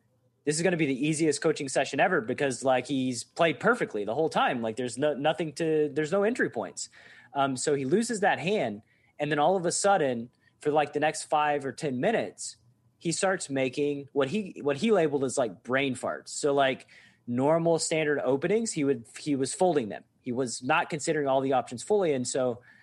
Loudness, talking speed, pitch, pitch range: -28 LUFS, 210 wpm, 145 Hz, 130-160 Hz